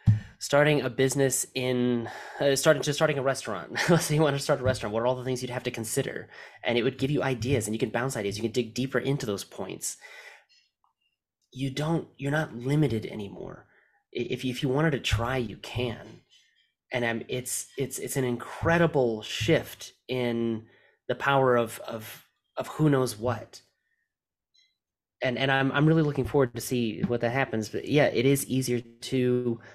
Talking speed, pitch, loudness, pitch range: 190 wpm, 130 Hz, -27 LUFS, 120-140 Hz